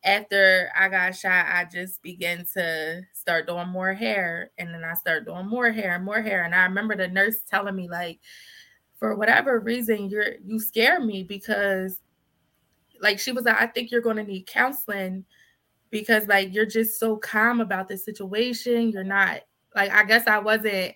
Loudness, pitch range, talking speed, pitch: -23 LUFS, 185-220 Hz, 185 wpm, 200 Hz